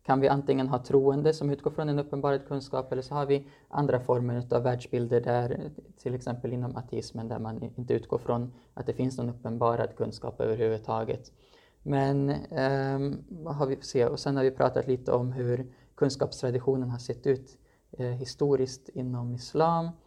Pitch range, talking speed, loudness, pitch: 125-140 Hz, 175 wpm, -30 LUFS, 130 Hz